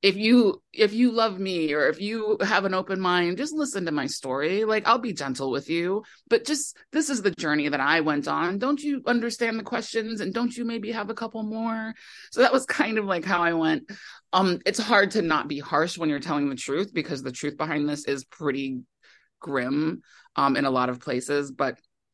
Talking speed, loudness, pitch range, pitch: 225 wpm, -25 LUFS, 150-230 Hz, 195 Hz